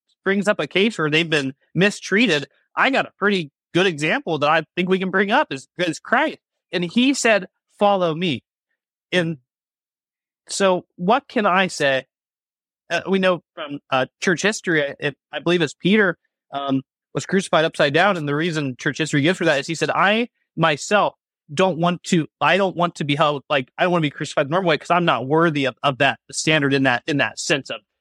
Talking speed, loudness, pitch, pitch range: 210 wpm, -20 LUFS, 170 Hz, 145-190 Hz